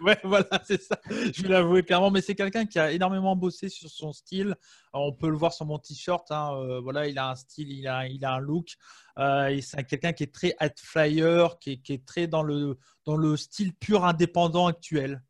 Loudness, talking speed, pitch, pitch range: -27 LUFS, 235 wpm, 160 Hz, 140-185 Hz